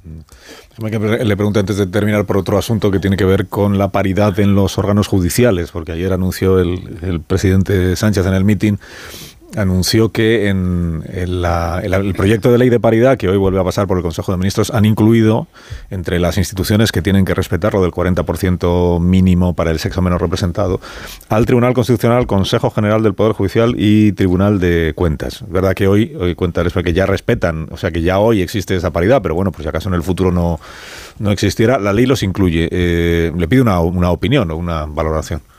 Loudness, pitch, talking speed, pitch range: -15 LUFS, 95 Hz, 205 wpm, 90-105 Hz